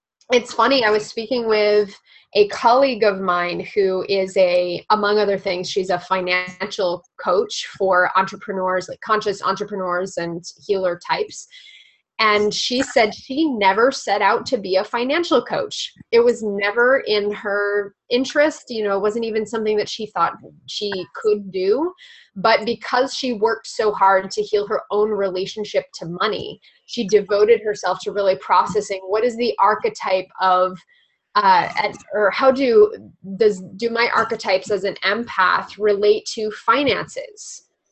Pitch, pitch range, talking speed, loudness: 210 Hz, 190-245 Hz, 155 wpm, -19 LUFS